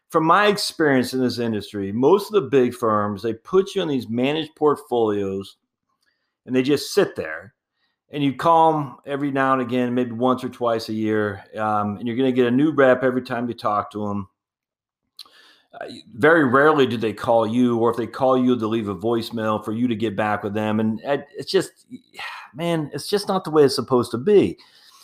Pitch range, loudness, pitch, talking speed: 110-140 Hz, -21 LUFS, 125 Hz, 210 wpm